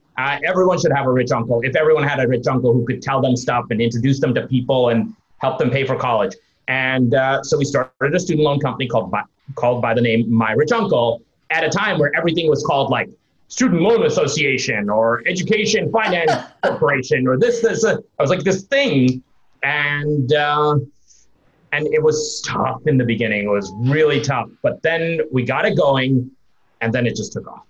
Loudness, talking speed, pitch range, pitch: -18 LUFS, 210 wpm, 120-155 Hz, 135 Hz